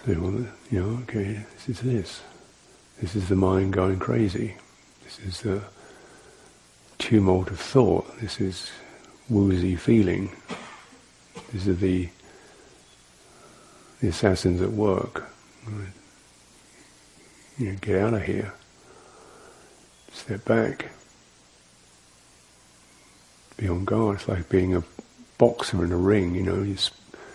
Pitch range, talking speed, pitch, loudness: 85-105 Hz, 120 wpm, 95 Hz, -25 LUFS